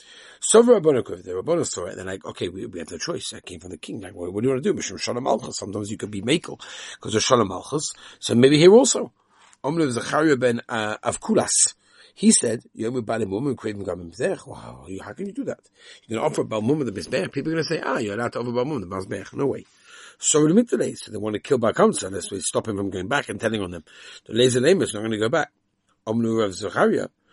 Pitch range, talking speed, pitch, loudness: 105-155 Hz, 250 wpm, 120 Hz, -22 LUFS